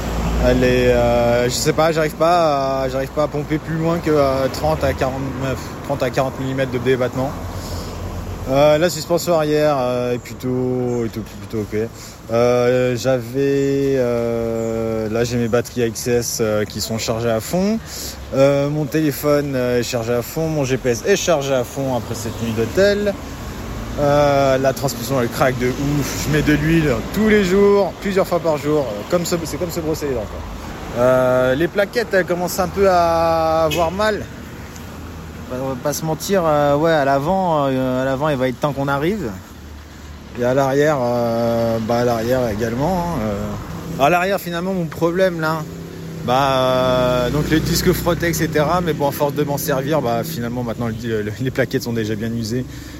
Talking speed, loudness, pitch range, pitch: 185 wpm, -18 LUFS, 120-155 Hz, 135 Hz